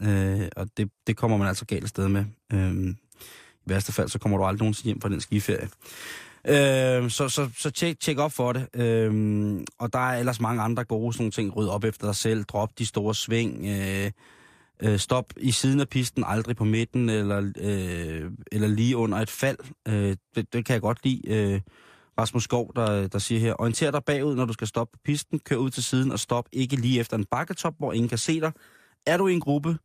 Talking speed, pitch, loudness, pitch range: 230 wpm, 115 Hz, -26 LUFS, 105-130 Hz